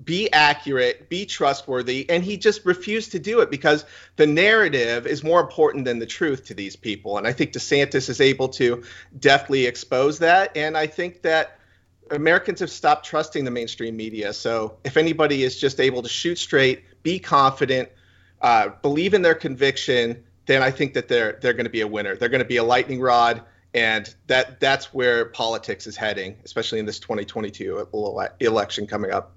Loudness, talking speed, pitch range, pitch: -21 LUFS, 190 wpm, 120-155 Hz, 135 Hz